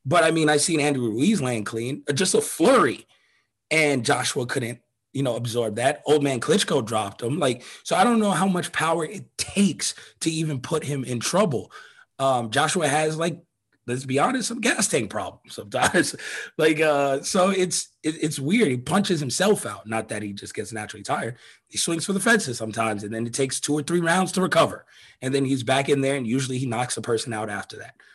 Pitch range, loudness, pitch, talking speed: 125-170 Hz, -23 LUFS, 145 Hz, 215 wpm